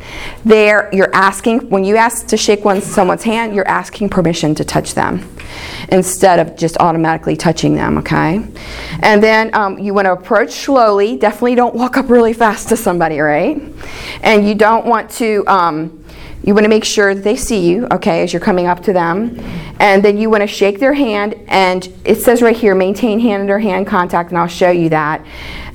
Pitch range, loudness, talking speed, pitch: 175-220 Hz, -12 LUFS, 200 wpm, 200 Hz